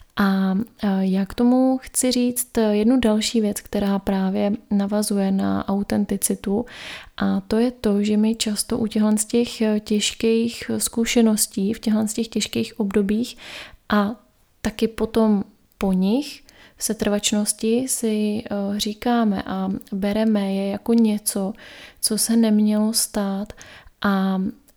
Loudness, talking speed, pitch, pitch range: -21 LUFS, 125 wpm, 215 Hz, 205-230 Hz